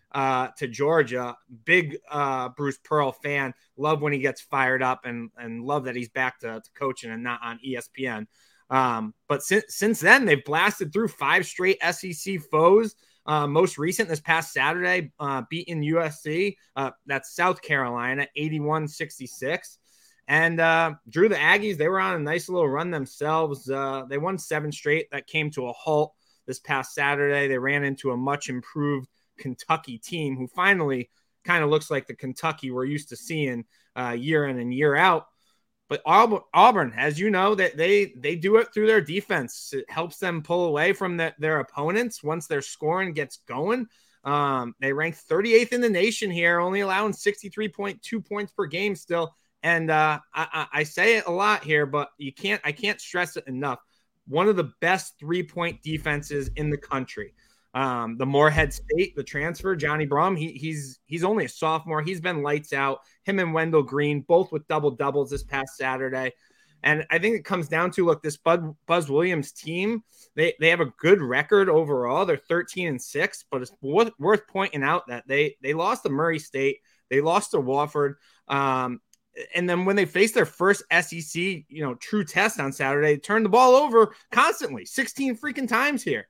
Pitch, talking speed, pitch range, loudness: 155 Hz, 185 wpm, 140-185 Hz, -24 LUFS